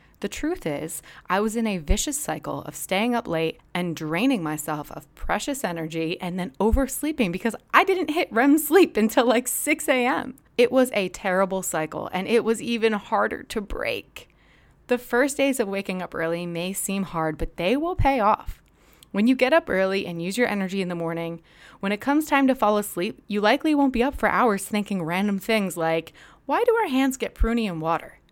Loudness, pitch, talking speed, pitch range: -24 LUFS, 215 Hz, 205 wpm, 180-260 Hz